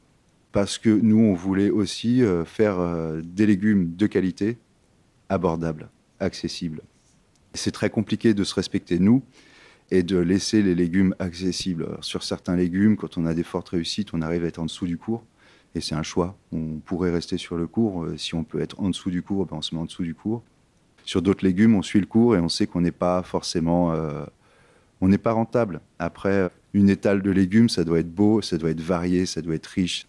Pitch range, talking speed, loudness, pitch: 85-105 Hz, 210 wpm, -23 LUFS, 95 Hz